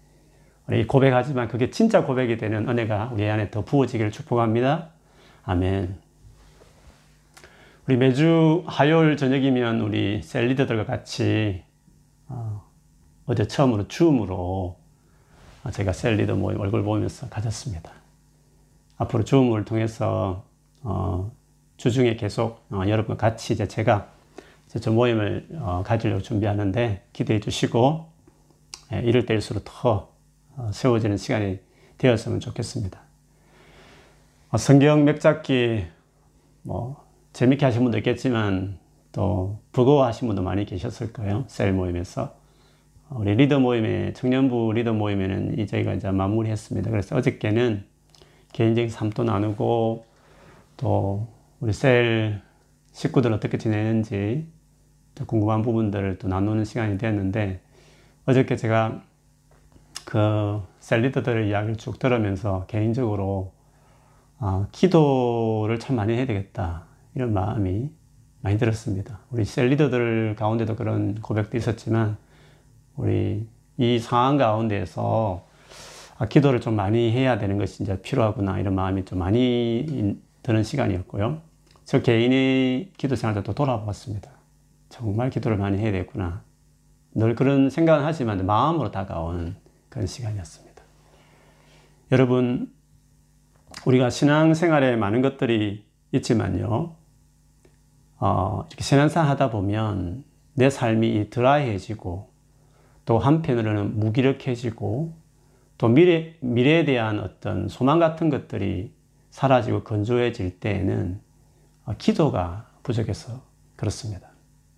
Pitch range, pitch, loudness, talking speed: 105-130 Hz, 115 Hz, -23 LUFS, 270 characters per minute